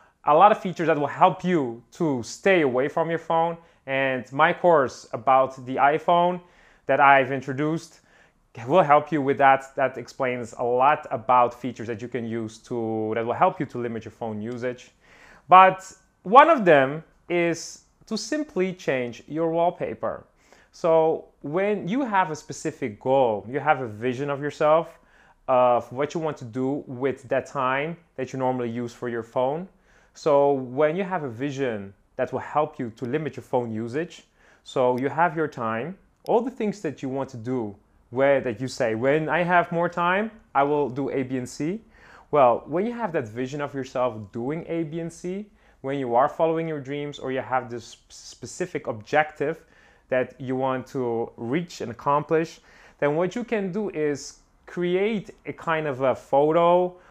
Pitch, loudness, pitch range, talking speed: 145 Hz, -24 LUFS, 125-170 Hz, 185 wpm